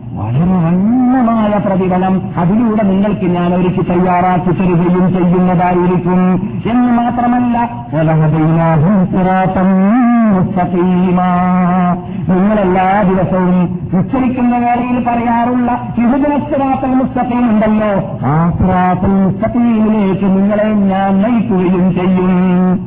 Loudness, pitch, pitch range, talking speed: -12 LUFS, 185 Hz, 180-225 Hz, 70 wpm